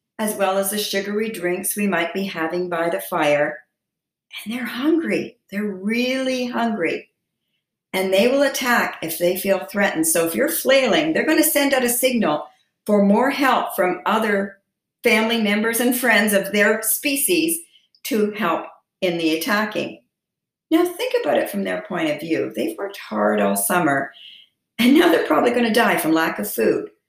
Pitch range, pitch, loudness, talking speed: 185-250 Hz, 210 Hz, -19 LUFS, 175 wpm